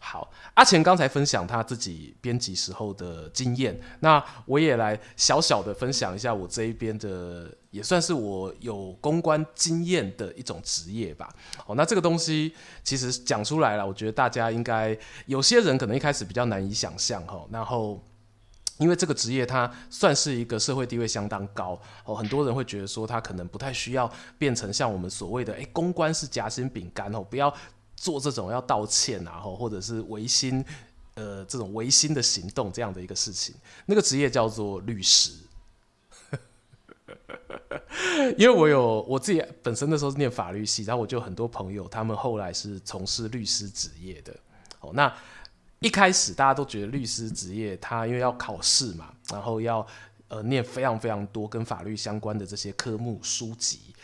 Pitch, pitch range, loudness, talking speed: 115 Hz, 105-135 Hz, -26 LUFS, 285 characters per minute